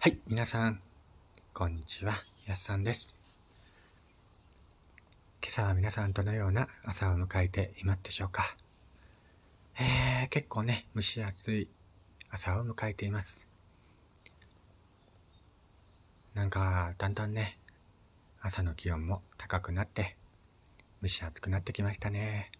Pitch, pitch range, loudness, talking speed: 100 Hz, 90-105 Hz, -34 LUFS, 235 characters per minute